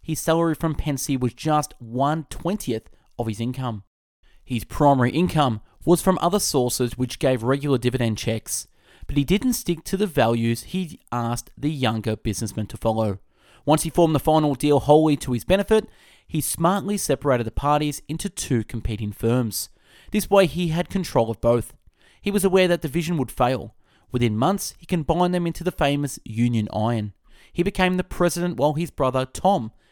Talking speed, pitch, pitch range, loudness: 175 wpm, 140 Hz, 120-170 Hz, -23 LUFS